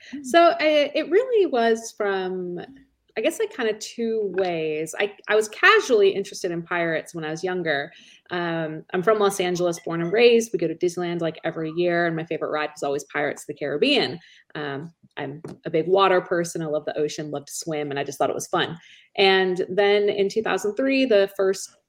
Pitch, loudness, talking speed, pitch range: 185 Hz, -23 LUFS, 205 wpm, 160-220 Hz